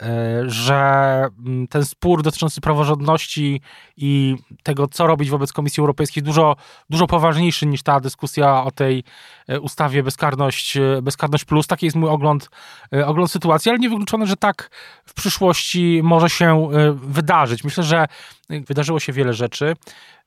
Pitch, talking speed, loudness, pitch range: 150 Hz, 135 wpm, -18 LUFS, 140-165 Hz